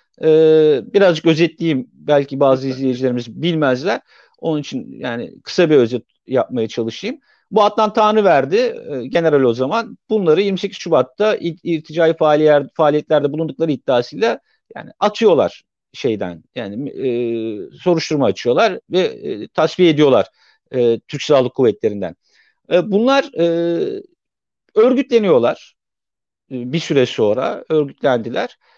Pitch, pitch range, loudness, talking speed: 165 Hz, 140-225 Hz, -17 LUFS, 115 wpm